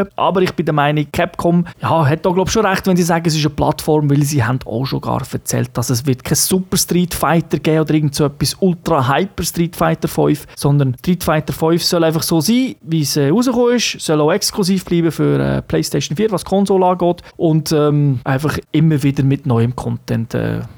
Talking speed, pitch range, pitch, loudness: 220 wpm, 145-175 Hz, 160 Hz, -16 LUFS